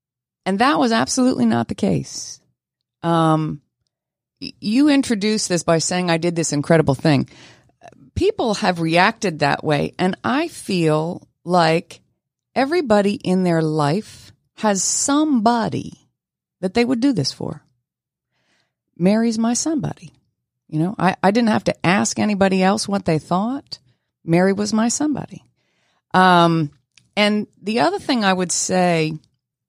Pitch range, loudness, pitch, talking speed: 155-225 Hz, -19 LUFS, 180 Hz, 135 wpm